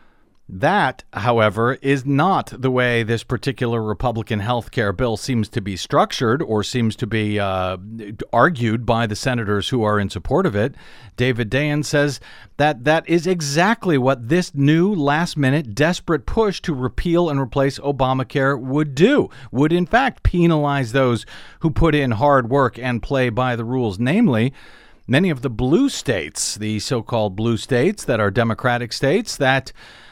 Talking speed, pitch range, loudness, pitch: 165 wpm, 115-145 Hz, -19 LUFS, 130 Hz